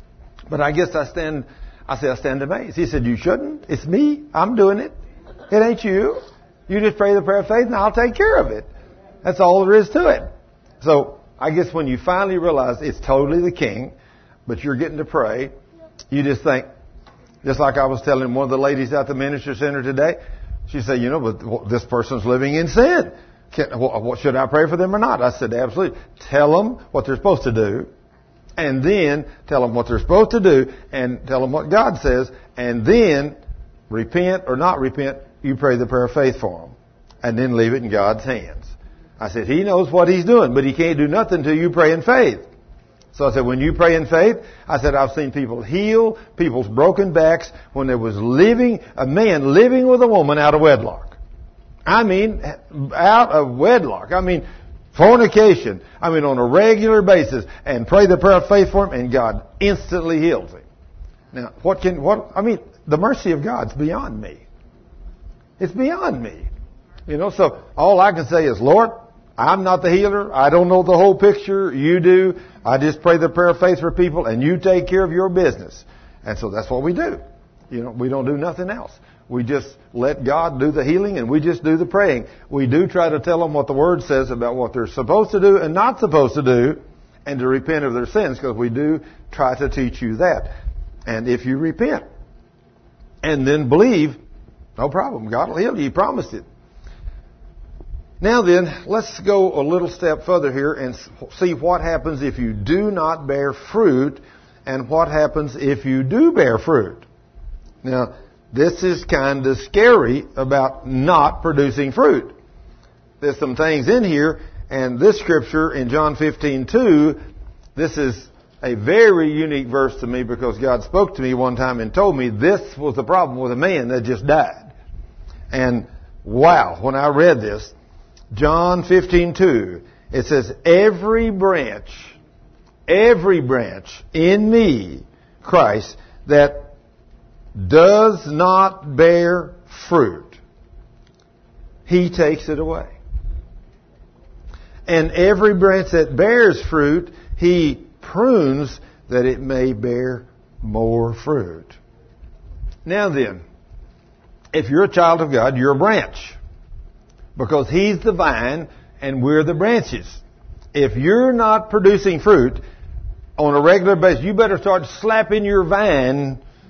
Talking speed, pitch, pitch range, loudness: 175 wpm, 150 Hz, 130-185 Hz, -17 LUFS